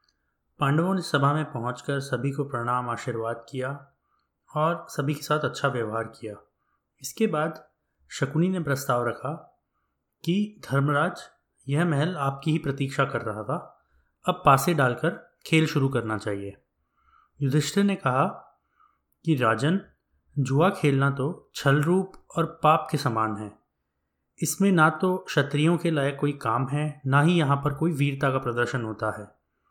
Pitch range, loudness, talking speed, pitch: 120-155 Hz, -26 LUFS, 150 wpm, 140 Hz